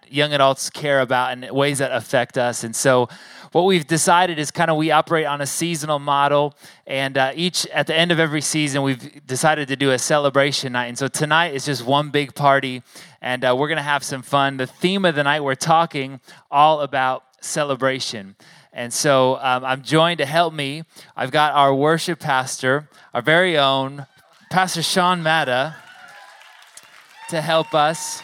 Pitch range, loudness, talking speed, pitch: 135-160 Hz, -19 LUFS, 185 wpm, 145 Hz